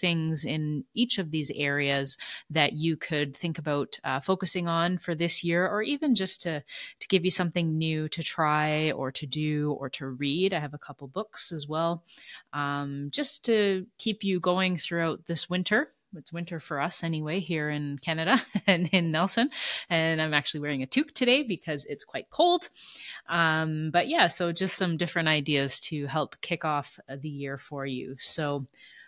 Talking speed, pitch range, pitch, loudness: 185 wpm, 145-180 Hz, 160 Hz, -27 LUFS